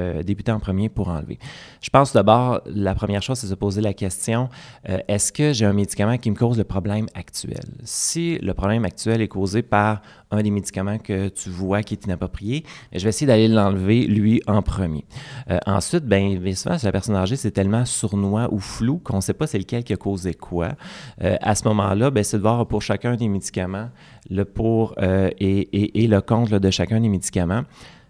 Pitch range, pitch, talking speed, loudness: 95-115 Hz, 105 Hz, 215 wpm, -21 LUFS